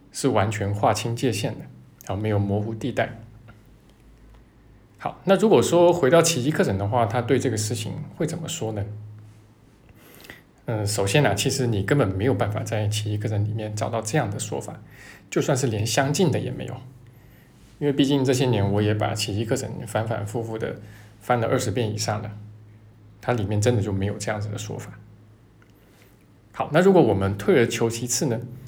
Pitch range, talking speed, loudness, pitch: 105-130 Hz, 275 characters per minute, -23 LUFS, 115 Hz